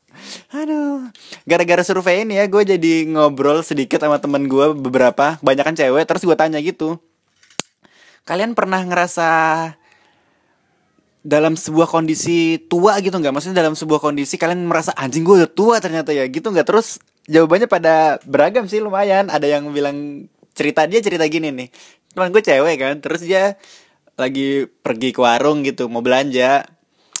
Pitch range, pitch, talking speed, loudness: 145-185 Hz, 160 Hz, 150 wpm, -16 LUFS